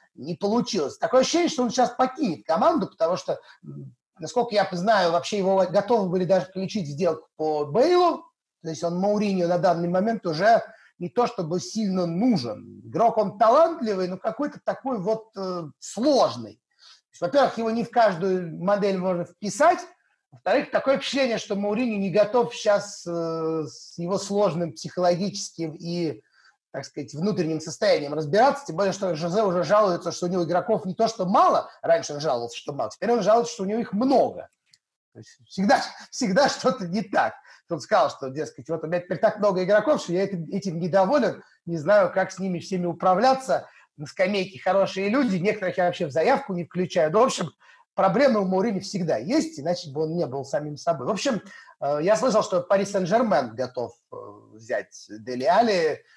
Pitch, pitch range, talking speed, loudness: 190 Hz, 170-225 Hz, 180 wpm, -24 LUFS